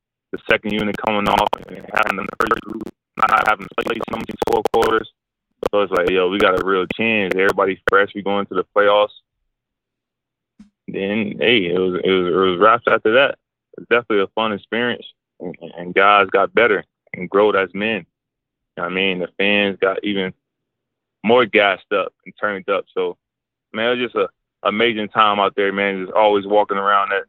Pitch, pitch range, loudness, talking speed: 100 Hz, 100-110 Hz, -18 LUFS, 195 wpm